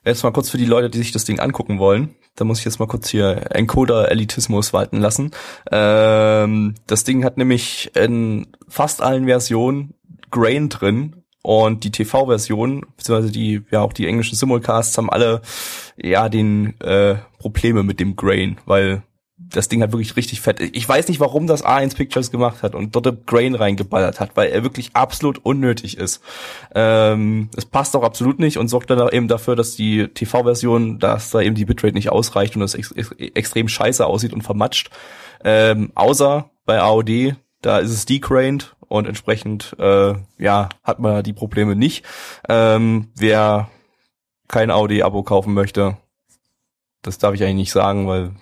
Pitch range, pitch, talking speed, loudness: 105-125 Hz, 110 Hz, 175 wpm, -17 LUFS